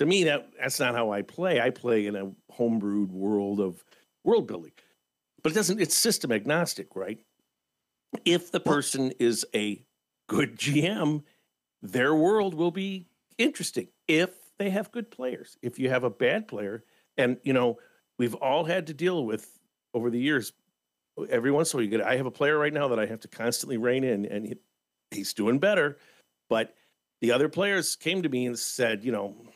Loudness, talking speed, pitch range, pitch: -27 LUFS, 195 wpm, 105-165 Hz, 125 Hz